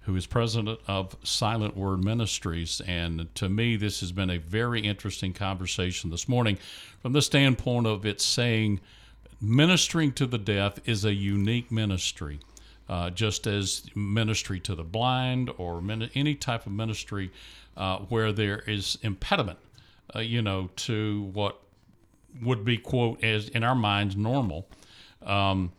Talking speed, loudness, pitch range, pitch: 150 wpm, -28 LUFS, 95-115 Hz, 105 Hz